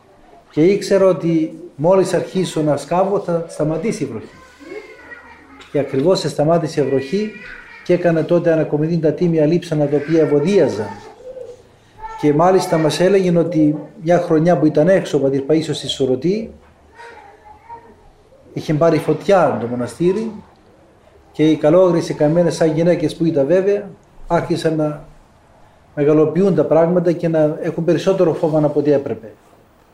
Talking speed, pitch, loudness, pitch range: 135 wpm, 165 Hz, -16 LUFS, 150-185 Hz